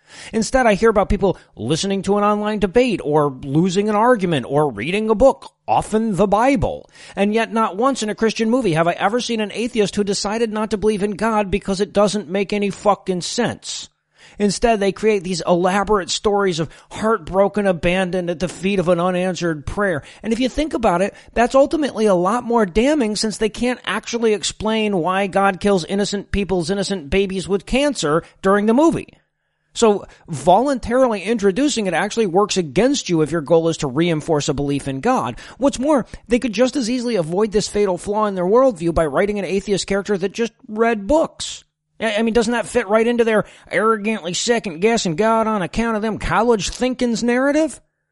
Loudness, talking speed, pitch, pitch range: -18 LUFS, 190 wpm, 205 Hz, 185-230 Hz